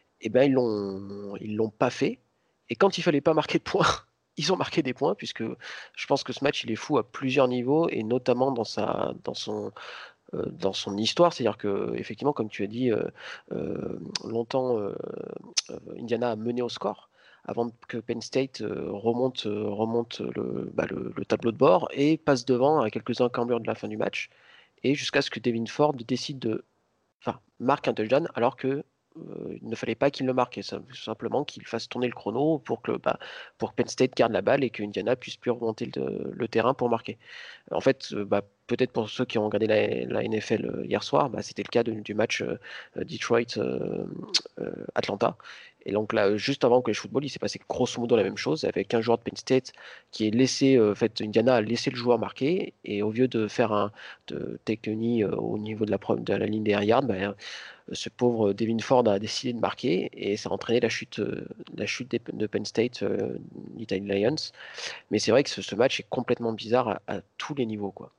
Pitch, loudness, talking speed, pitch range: 115 Hz, -27 LUFS, 225 wpm, 110-130 Hz